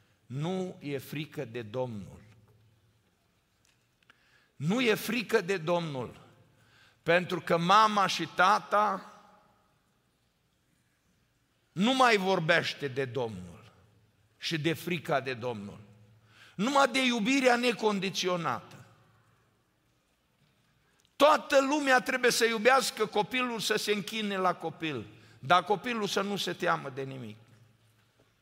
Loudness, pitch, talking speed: -28 LUFS, 175 Hz, 100 wpm